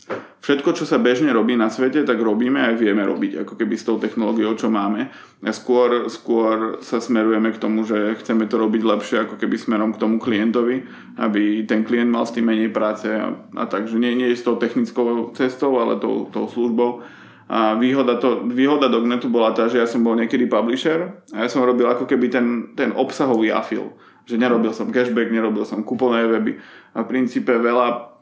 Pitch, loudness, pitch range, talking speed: 120 Hz, -20 LUFS, 110-125 Hz, 200 wpm